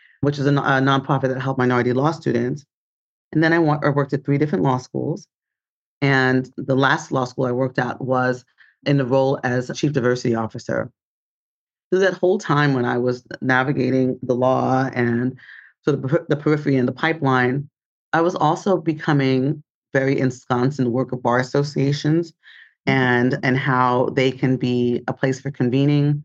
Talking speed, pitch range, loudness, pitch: 180 wpm, 125-145 Hz, -20 LUFS, 135 Hz